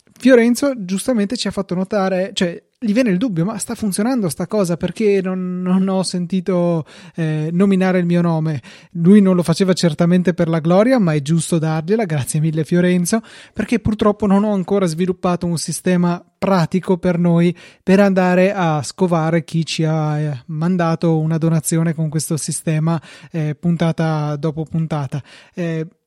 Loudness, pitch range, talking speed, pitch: -17 LUFS, 165-195 Hz, 165 wpm, 175 Hz